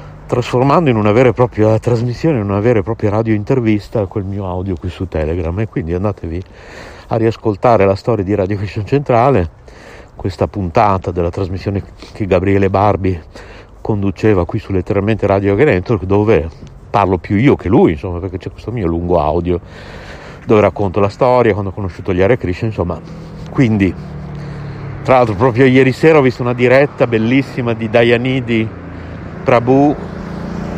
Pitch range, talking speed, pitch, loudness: 95-125 Hz, 160 wpm, 110 Hz, -14 LUFS